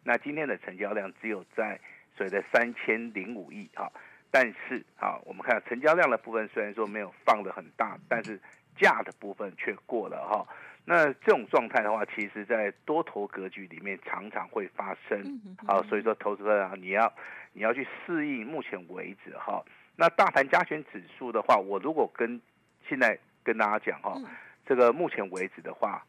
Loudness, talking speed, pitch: -29 LUFS, 275 characters per minute, 145 Hz